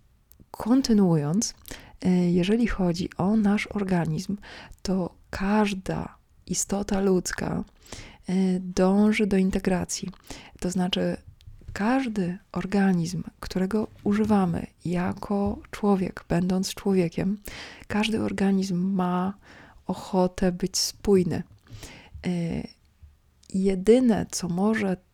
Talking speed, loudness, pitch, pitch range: 75 wpm, -26 LUFS, 185 Hz, 175-205 Hz